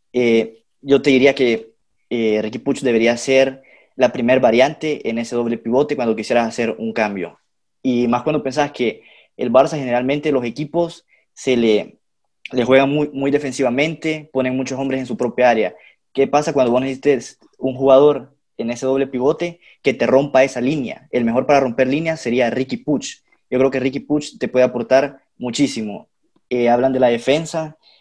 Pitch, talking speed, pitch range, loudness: 130 Hz, 180 wpm, 120-140 Hz, -18 LUFS